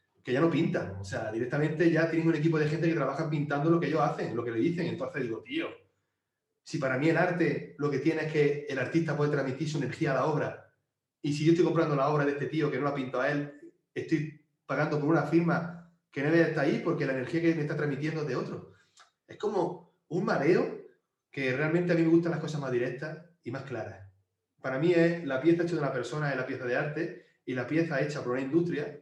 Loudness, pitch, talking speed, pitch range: -29 LUFS, 155 Hz, 245 wpm, 135-165 Hz